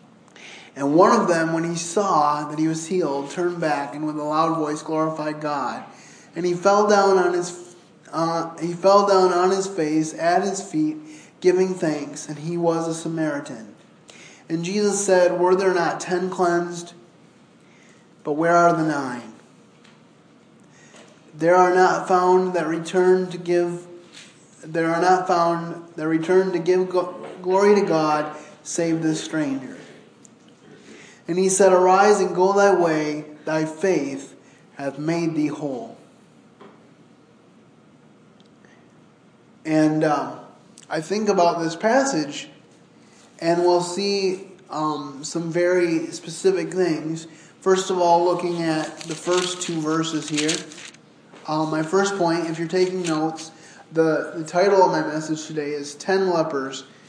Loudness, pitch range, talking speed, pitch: -21 LUFS, 155-185 Hz, 145 wpm, 170 Hz